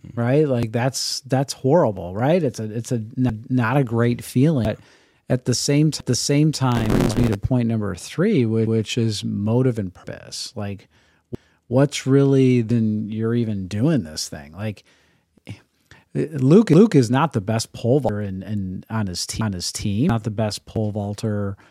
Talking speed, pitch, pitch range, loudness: 170 wpm, 115 Hz, 105-130 Hz, -21 LUFS